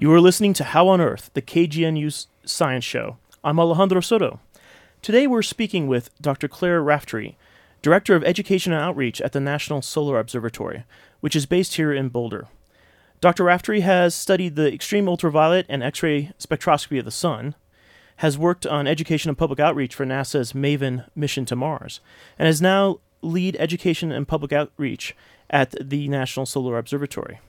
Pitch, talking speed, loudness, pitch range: 155 Hz, 165 wpm, -21 LUFS, 140-175 Hz